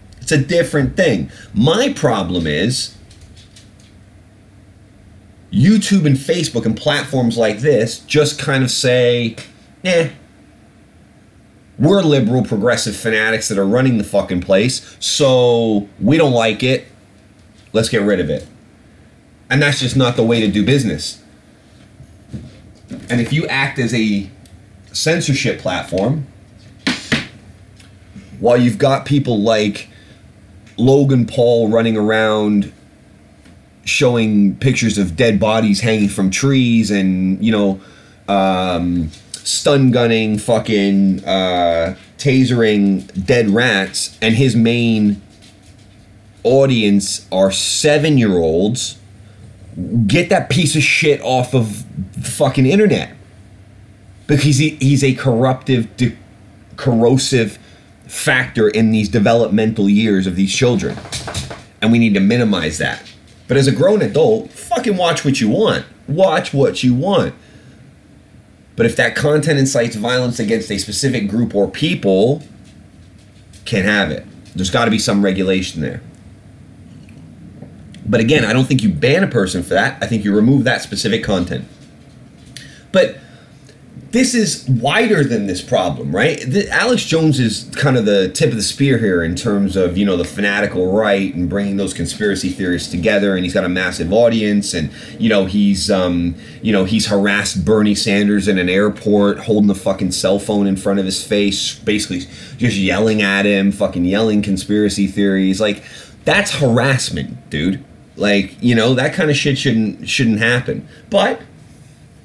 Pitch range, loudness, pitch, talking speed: 100-125 Hz, -15 LUFS, 110 Hz, 140 wpm